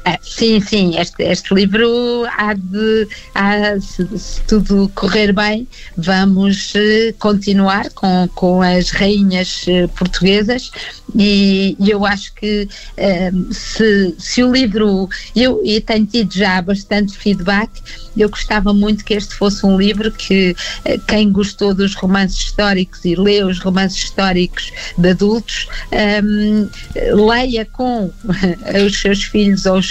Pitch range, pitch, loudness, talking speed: 190-215 Hz, 205 Hz, -14 LUFS, 140 wpm